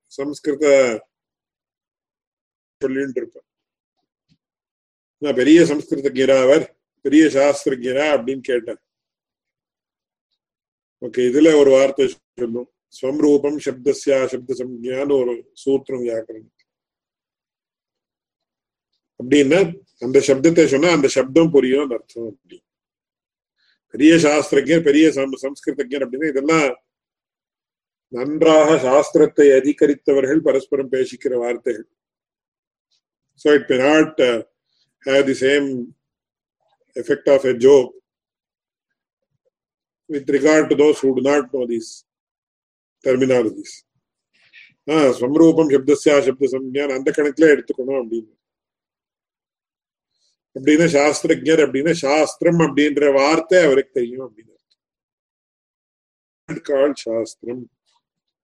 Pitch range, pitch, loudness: 130-155 Hz, 140 Hz, -17 LUFS